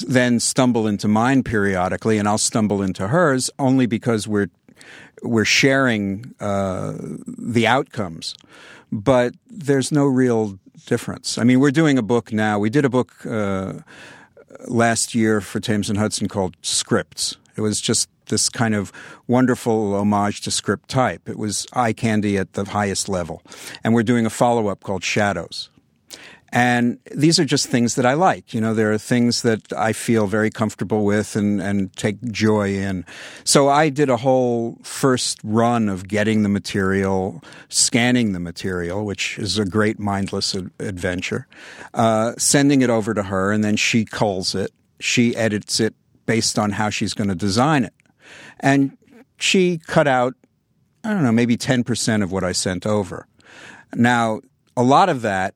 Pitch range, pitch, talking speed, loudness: 105-125 Hz, 110 Hz, 165 wpm, -19 LUFS